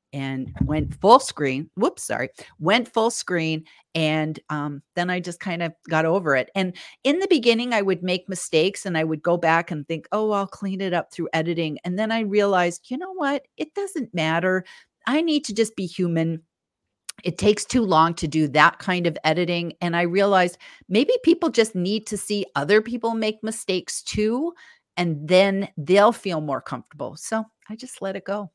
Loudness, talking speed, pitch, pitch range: -23 LUFS, 195 wpm, 185 Hz, 165-215 Hz